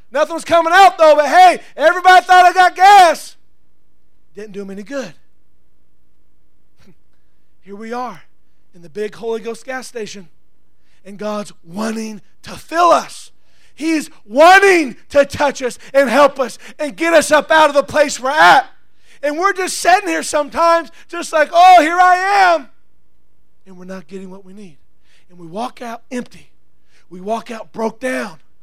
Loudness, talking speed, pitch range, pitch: -12 LUFS, 170 wpm, 200-325 Hz, 255 Hz